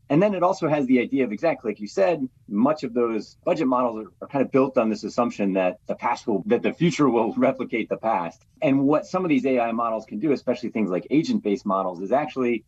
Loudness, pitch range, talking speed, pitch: -23 LUFS, 110-145 Hz, 250 wpm, 120 Hz